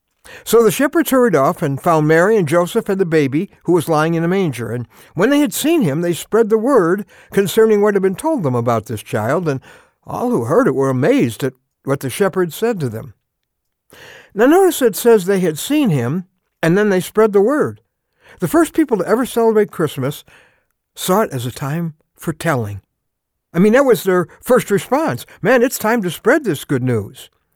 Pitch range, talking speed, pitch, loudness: 140-220 Hz, 205 wpm, 175 Hz, -16 LUFS